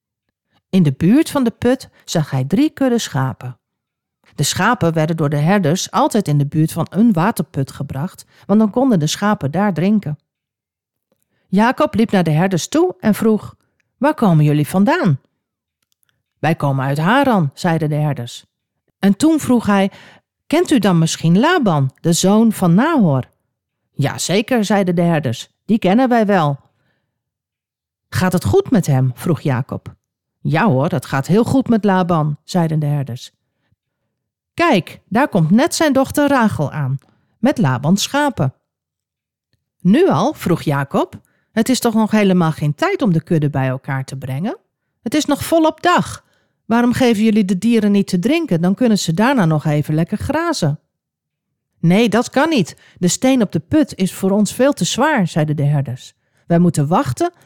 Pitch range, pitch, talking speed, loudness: 145-230 Hz, 185 Hz, 170 wpm, -16 LUFS